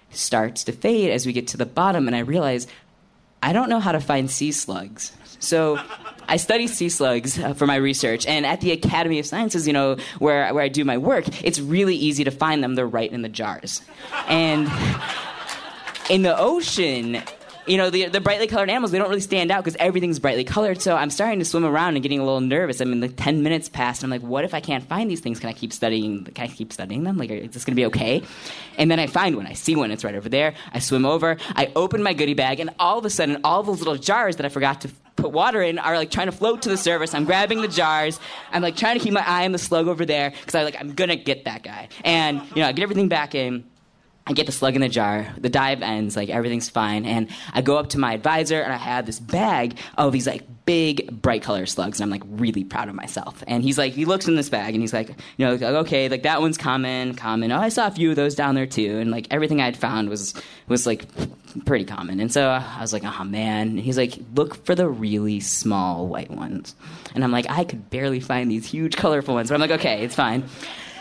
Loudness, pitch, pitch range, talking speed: -22 LUFS, 140 Hz, 120-165 Hz, 260 wpm